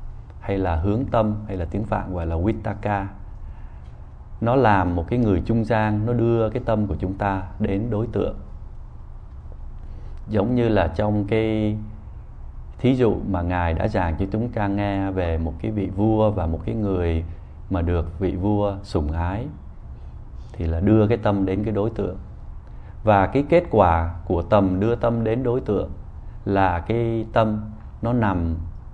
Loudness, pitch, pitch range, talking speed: -22 LUFS, 100 Hz, 85-110 Hz, 170 wpm